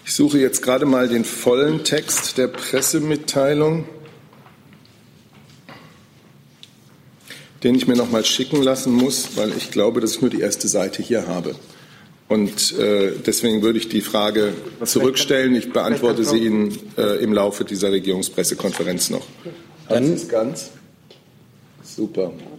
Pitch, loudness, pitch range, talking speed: 125 Hz, -19 LUFS, 110-145 Hz, 130 wpm